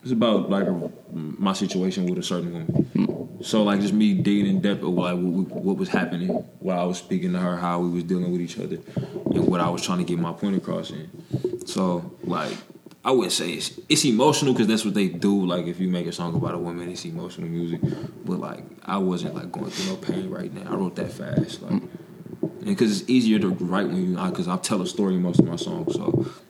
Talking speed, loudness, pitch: 240 wpm, -24 LUFS, 100 Hz